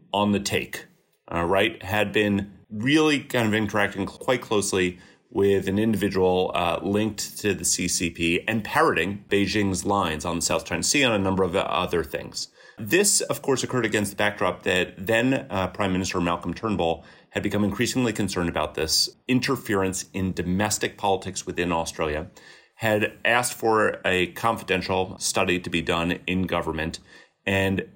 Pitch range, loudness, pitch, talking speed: 90-110 Hz, -24 LUFS, 100 Hz, 160 wpm